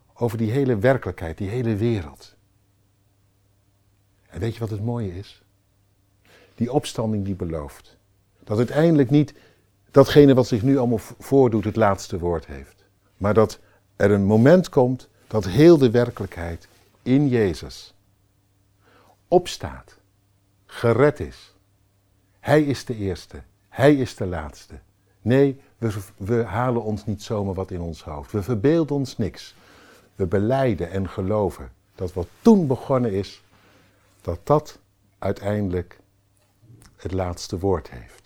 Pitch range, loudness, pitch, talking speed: 95-120 Hz, -21 LUFS, 100 Hz, 135 wpm